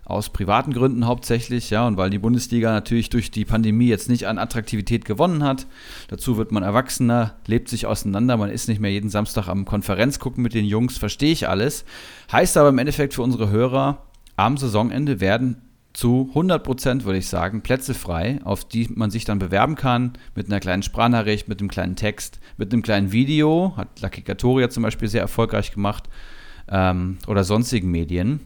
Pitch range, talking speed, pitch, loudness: 105-125 Hz, 185 wpm, 115 Hz, -21 LUFS